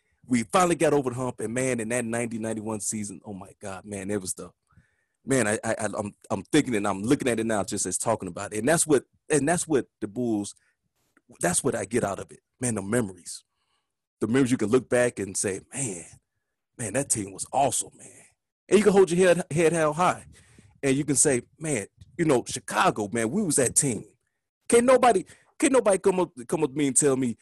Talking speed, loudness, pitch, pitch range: 230 wpm, -25 LUFS, 120 Hz, 105-150 Hz